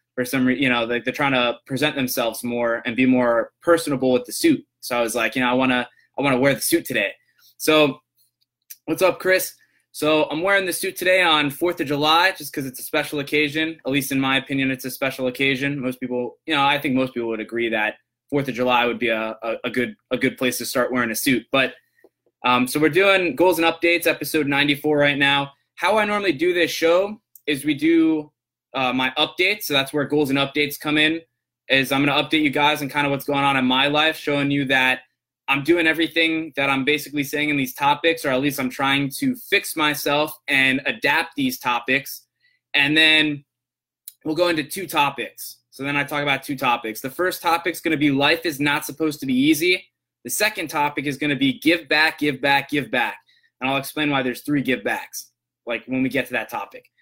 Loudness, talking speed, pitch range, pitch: -20 LUFS, 230 wpm, 130-160 Hz, 145 Hz